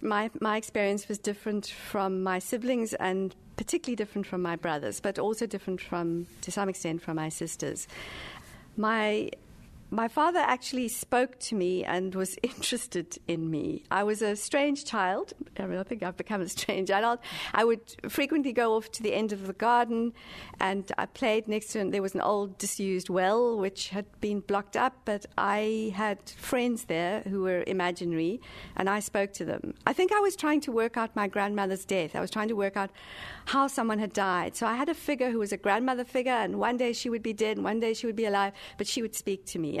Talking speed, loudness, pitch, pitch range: 215 wpm, -30 LUFS, 210 Hz, 195-235 Hz